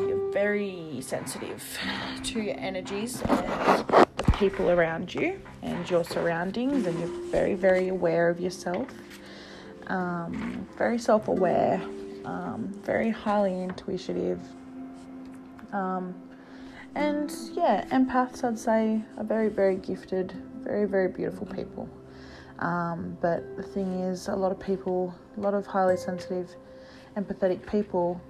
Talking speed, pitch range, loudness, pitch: 125 wpm, 170-215 Hz, -28 LUFS, 185 Hz